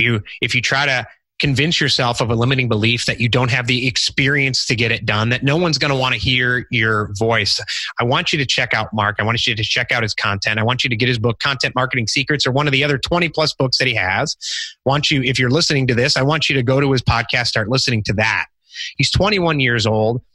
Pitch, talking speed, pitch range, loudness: 125 Hz, 270 wpm, 115-140 Hz, -16 LUFS